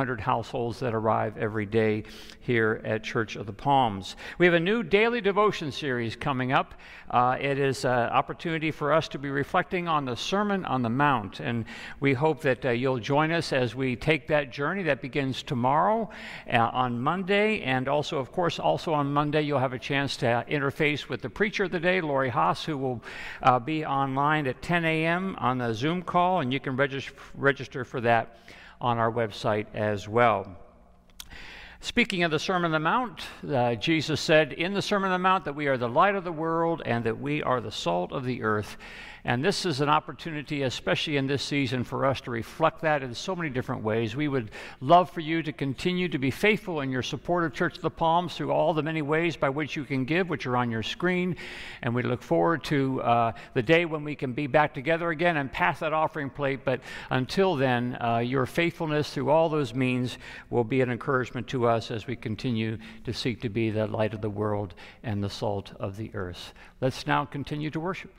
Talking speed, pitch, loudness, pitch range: 215 wpm, 140 Hz, -27 LUFS, 120-160 Hz